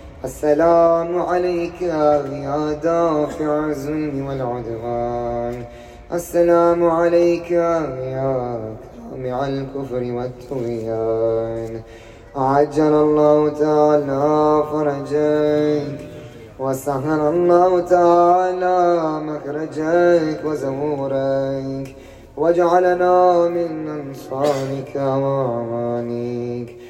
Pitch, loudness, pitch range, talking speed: 150 Hz, -19 LUFS, 130-165 Hz, 55 wpm